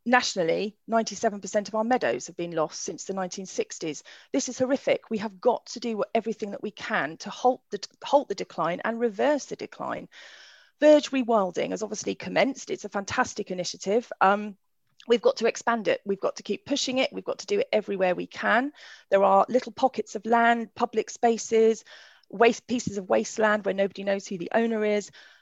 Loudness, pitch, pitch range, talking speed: -26 LUFS, 225 Hz, 205-255 Hz, 190 wpm